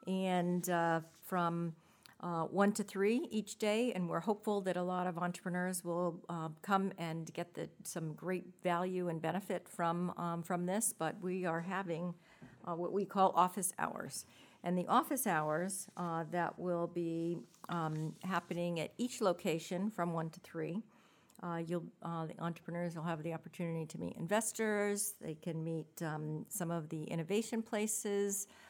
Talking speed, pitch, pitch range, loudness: 165 wpm, 175 Hz, 170-200 Hz, -38 LUFS